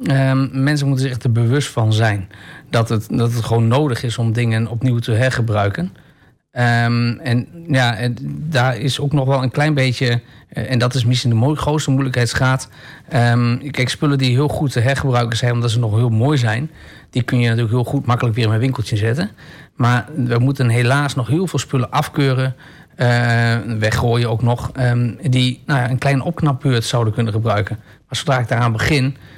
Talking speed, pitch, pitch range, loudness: 195 wpm, 125 Hz, 120-135 Hz, -17 LUFS